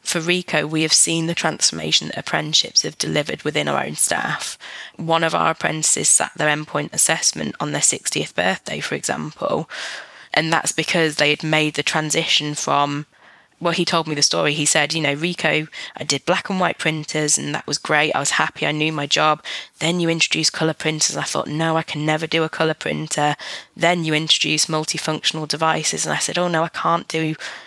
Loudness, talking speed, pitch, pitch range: -19 LUFS, 205 wpm, 155 Hz, 150-165 Hz